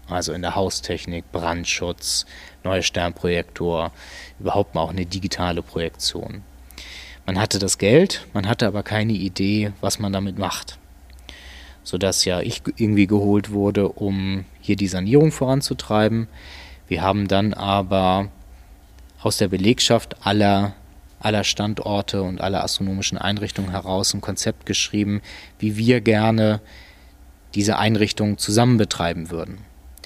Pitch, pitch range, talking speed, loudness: 95 Hz, 85-105 Hz, 125 wpm, -21 LUFS